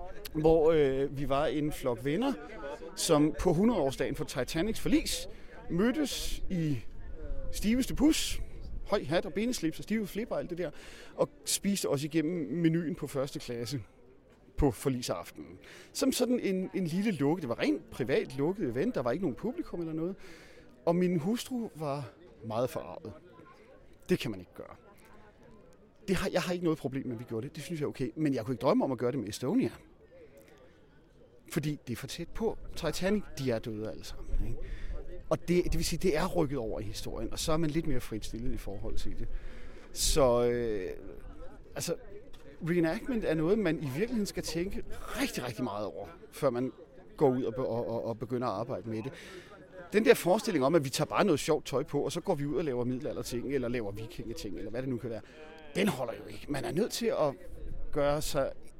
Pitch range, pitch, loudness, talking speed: 125-185 Hz, 155 Hz, -32 LUFS, 200 wpm